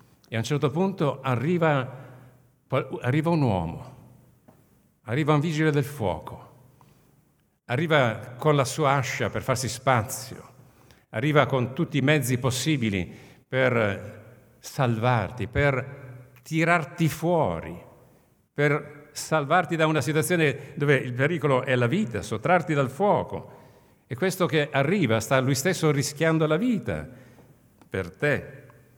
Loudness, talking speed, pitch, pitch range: -25 LUFS, 120 wpm, 140 Hz, 125-155 Hz